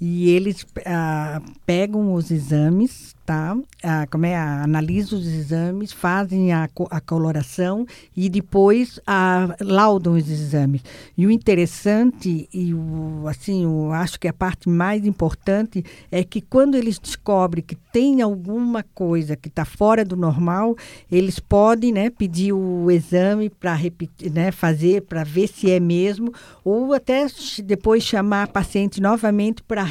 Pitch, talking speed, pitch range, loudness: 185 Hz, 150 wpm, 165-210 Hz, -20 LUFS